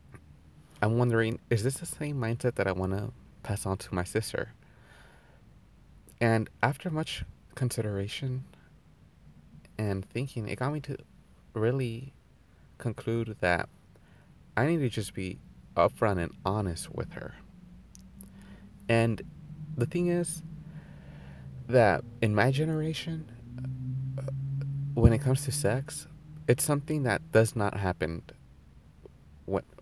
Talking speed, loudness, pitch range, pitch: 120 wpm, -30 LUFS, 95-135 Hz, 115 Hz